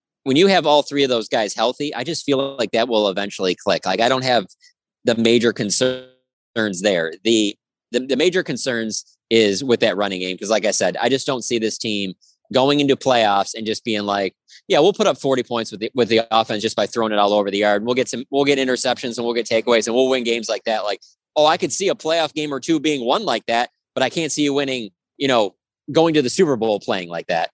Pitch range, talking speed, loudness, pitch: 110-135 Hz, 255 wpm, -19 LUFS, 120 Hz